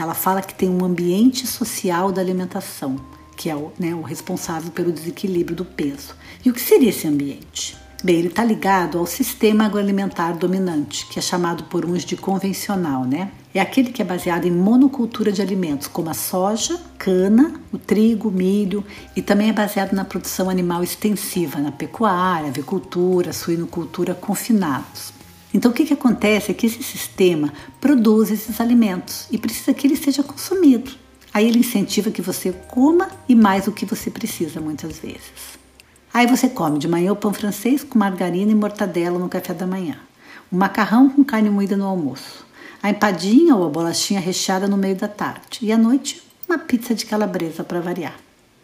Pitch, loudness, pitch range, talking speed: 195 Hz, -19 LUFS, 175-225 Hz, 180 wpm